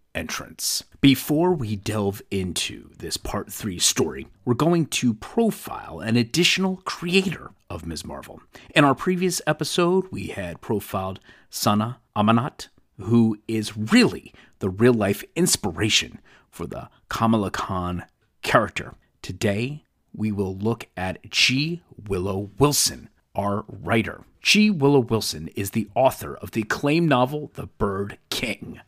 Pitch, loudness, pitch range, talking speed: 115 Hz, -23 LUFS, 100-145 Hz, 130 wpm